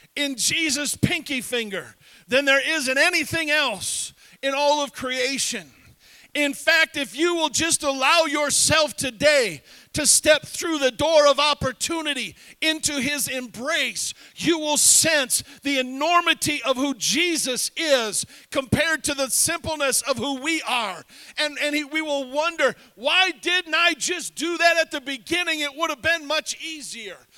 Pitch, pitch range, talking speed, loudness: 295 Hz, 270-320 Hz, 155 wpm, -21 LUFS